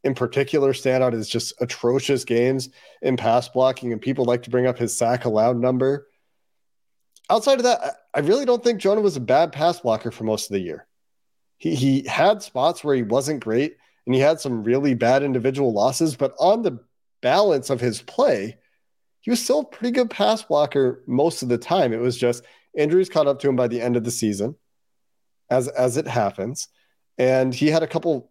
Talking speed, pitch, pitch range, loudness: 205 wpm, 130 Hz, 120-155 Hz, -21 LUFS